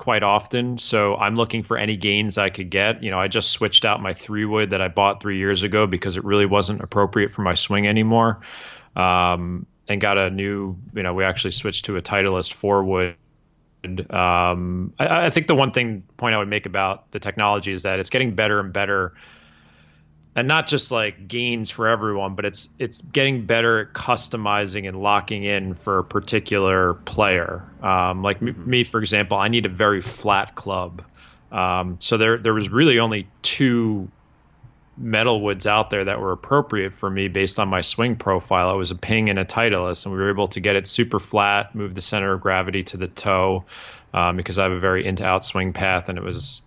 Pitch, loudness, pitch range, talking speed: 100 Hz, -20 LUFS, 95-110 Hz, 210 wpm